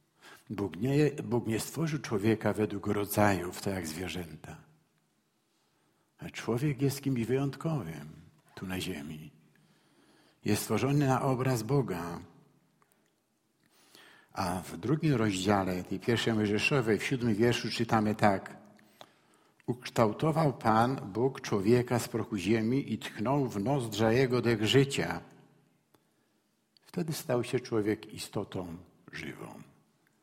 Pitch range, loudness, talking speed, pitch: 105-135 Hz, -31 LUFS, 110 wpm, 115 Hz